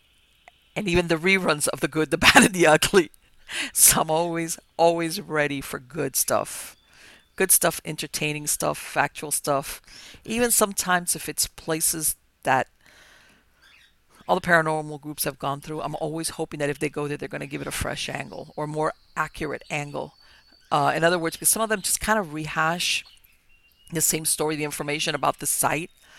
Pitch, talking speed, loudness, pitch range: 155 Hz, 180 wpm, -23 LUFS, 150-170 Hz